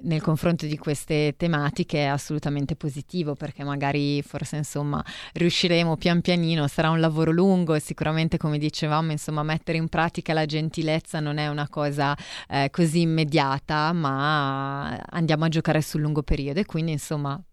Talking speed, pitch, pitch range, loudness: 155 wpm, 155 Hz, 145-165 Hz, -25 LUFS